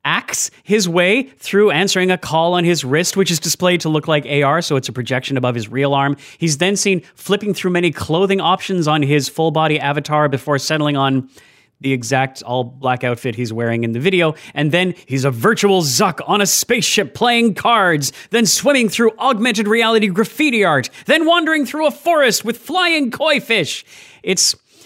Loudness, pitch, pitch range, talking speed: -16 LUFS, 175 Hz, 140-215 Hz, 190 wpm